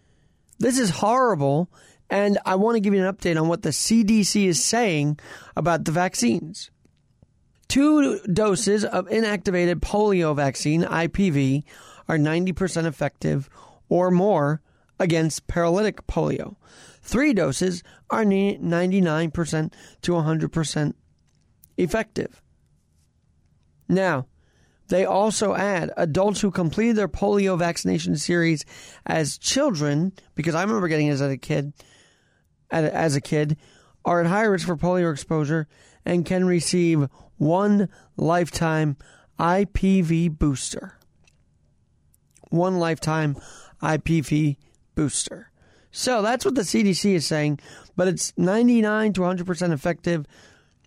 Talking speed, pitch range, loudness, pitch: 115 wpm, 155-195 Hz, -22 LUFS, 175 Hz